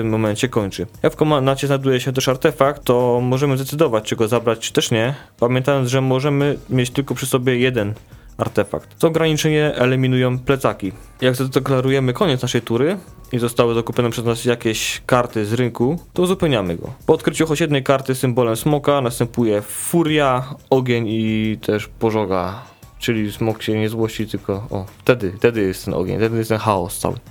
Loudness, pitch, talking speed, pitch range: -19 LUFS, 125 Hz, 170 wpm, 110-135 Hz